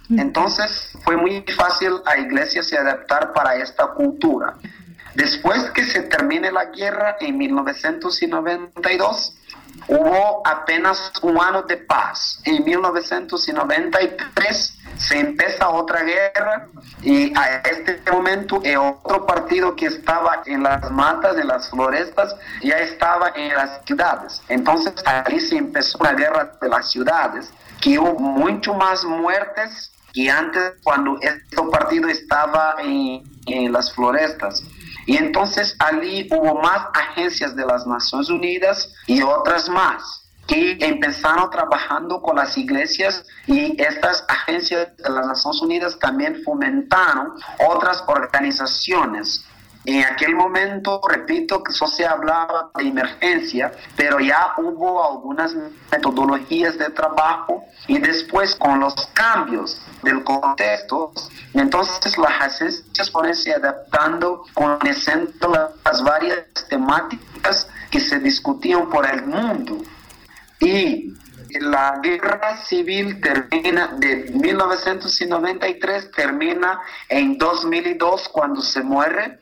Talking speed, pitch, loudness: 120 wpm, 190 Hz, -18 LUFS